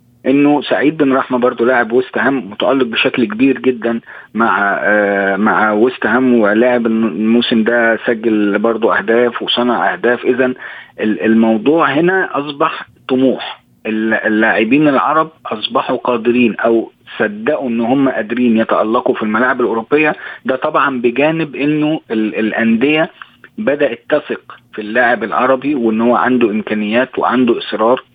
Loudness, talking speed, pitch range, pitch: -14 LUFS, 130 wpm, 115-130 Hz, 120 Hz